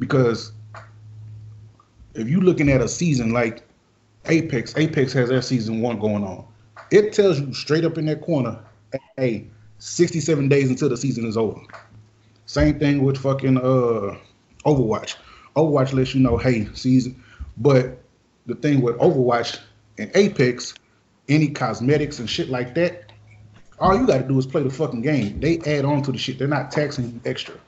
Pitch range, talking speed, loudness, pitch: 110-145 Hz, 165 wpm, -21 LUFS, 125 Hz